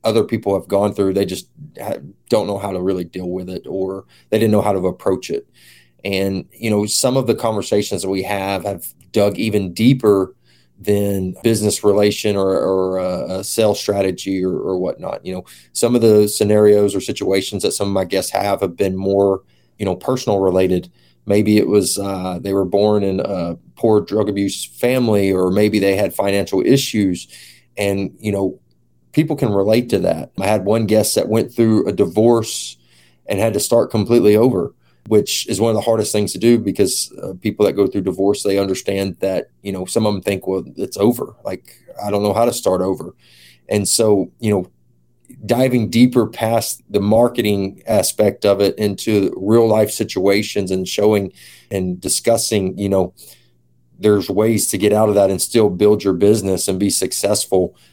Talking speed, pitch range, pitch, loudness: 190 wpm, 95-105 Hz, 100 Hz, -17 LUFS